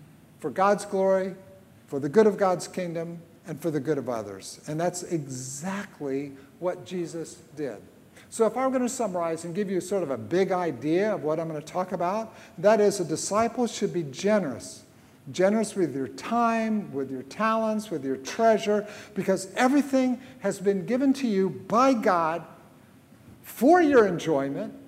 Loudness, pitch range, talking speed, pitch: -26 LUFS, 160-215 Hz, 170 wpm, 185 Hz